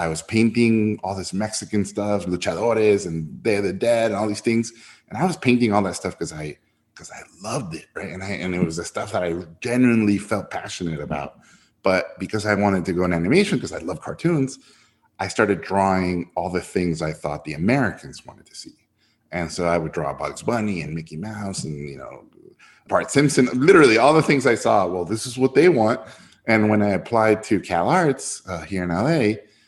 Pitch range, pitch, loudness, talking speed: 85-110 Hz, 100 Hz, -21 LUFS, 215 wpm